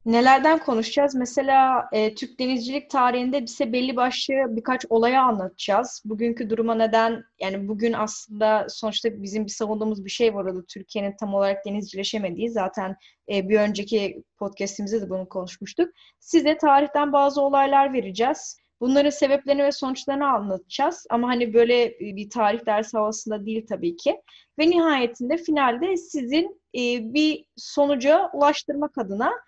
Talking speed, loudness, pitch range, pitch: 140 wpm, -23 LUFS, 215-280 Hz, 235 Hz